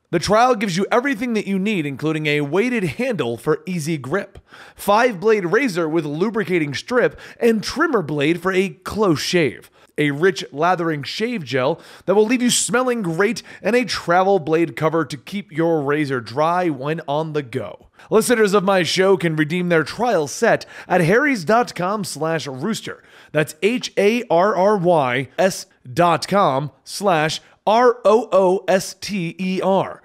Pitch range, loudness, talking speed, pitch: 155-210 Hz, -19 LUFS, 140 wpm, 185 Hz